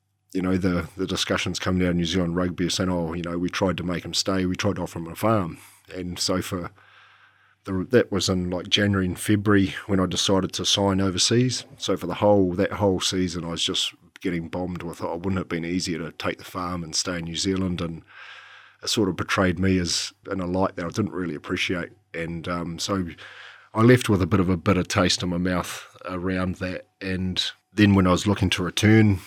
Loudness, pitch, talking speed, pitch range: -24 LUFS, 90 Hz, 235 wpm, 90-100 Hz